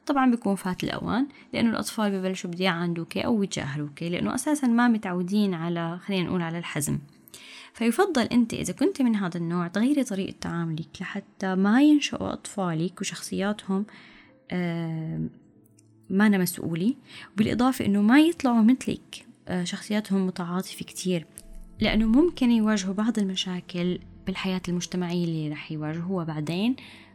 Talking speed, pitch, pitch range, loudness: 130 wpm, 190 Hz, 175-225 Hz, -26 LUFS